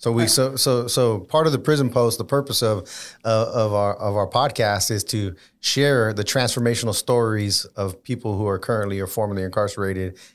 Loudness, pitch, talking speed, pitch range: -21 LUFS, 110 Hz, 190 wpm, 100-125 Hz